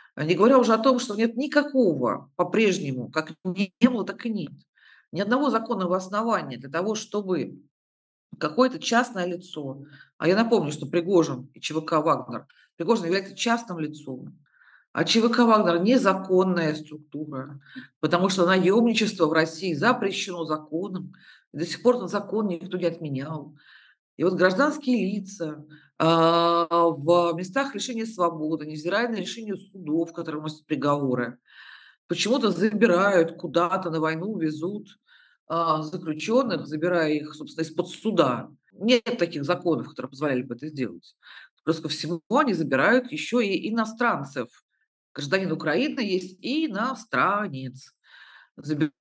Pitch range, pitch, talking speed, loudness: 155-220 Hz, 175 Hz, 130 wpm, -24 LUFS